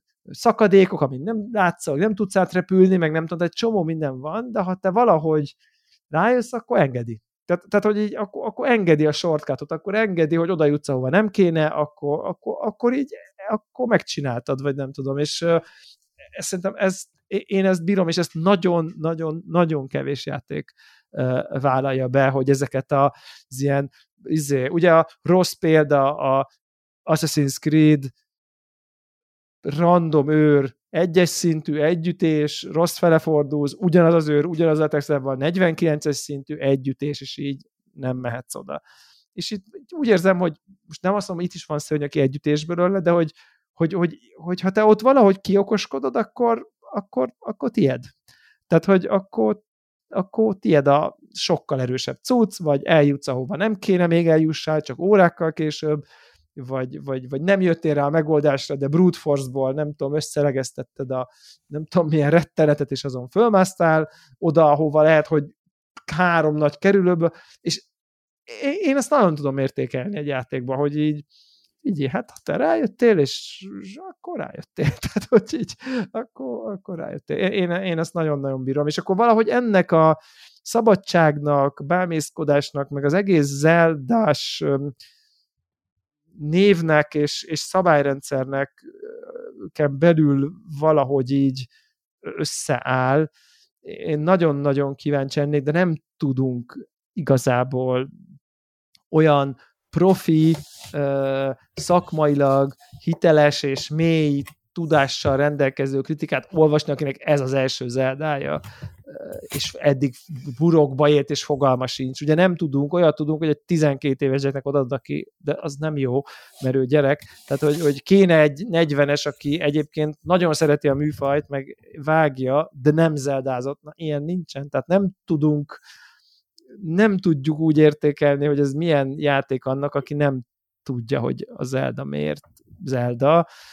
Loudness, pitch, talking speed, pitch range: -21 LUFS, 155 Hz, 140 wpm, 140-180 Hz